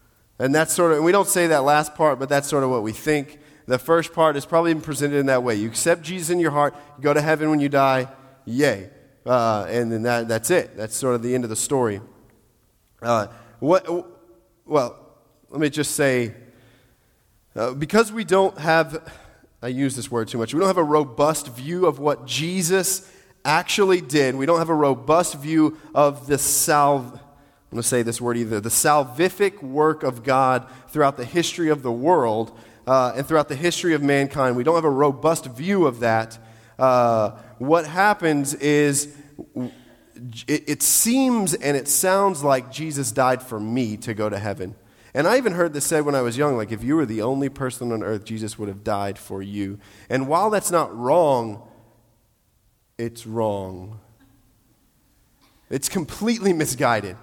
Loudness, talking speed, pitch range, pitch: -21 LUFS, 185 wpm, 115-155 Hz, 140 Hz